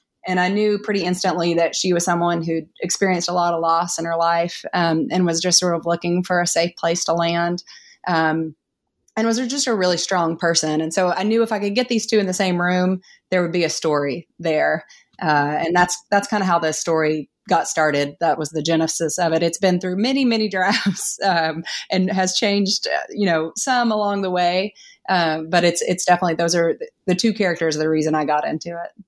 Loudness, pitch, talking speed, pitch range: -20 LUFS, 175 Hz, 225 wpm, 165-195 Hz